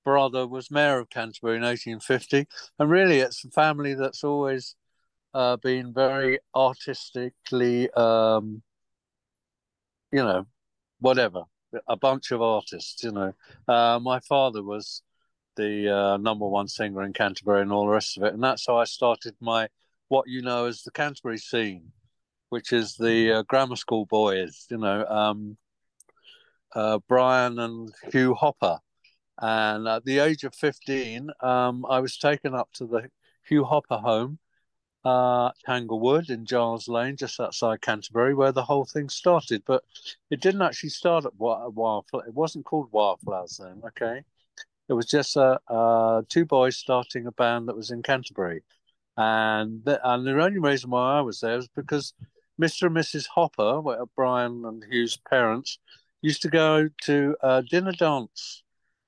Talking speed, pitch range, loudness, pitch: 160 wpm, 115-140 Hz, -25 LUFS, 125 Hz